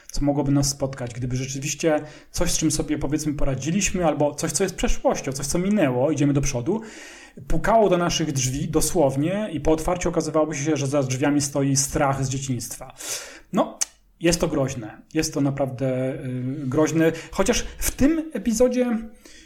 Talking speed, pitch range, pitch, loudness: 160 wpm, 140-175 Hz, 155 Hz, -23 LUFS